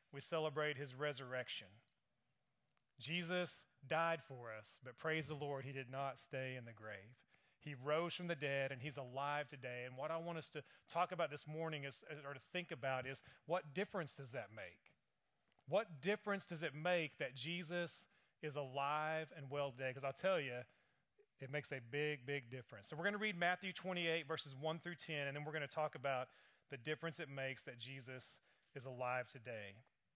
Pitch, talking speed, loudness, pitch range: 145 Hz, 195 wpm, -45 LUFS, 135-165 Hz